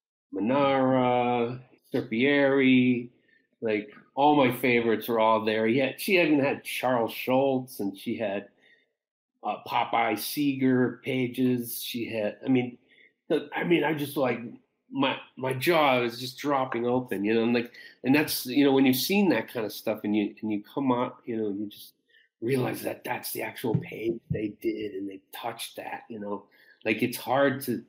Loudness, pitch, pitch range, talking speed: -27 LUFS, 125 Hz, 110-135 Hz, 180 wpm